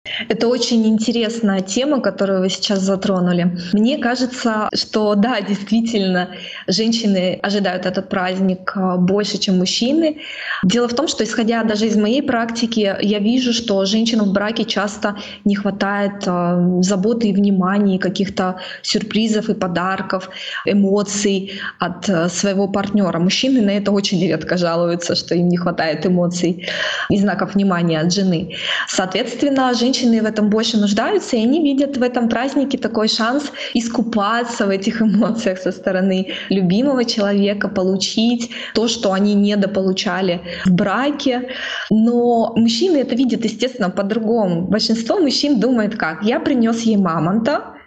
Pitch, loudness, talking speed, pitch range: 205 Hz, -17 LUFS, 140 wpm, 190-235 Hz